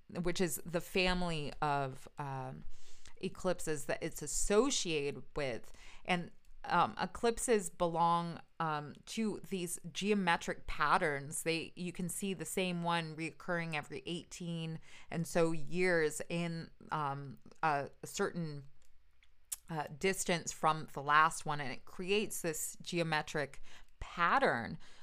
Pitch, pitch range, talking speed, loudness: 170 Hz, 150-180 Hz, 120 wpm, -36 LUFS